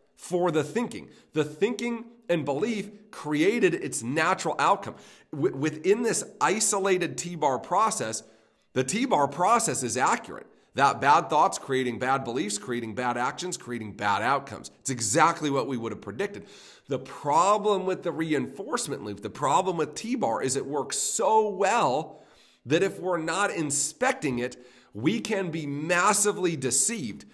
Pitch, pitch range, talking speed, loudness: 160 Hz, 125-200 Hz, 155 wpm, -26 LUFS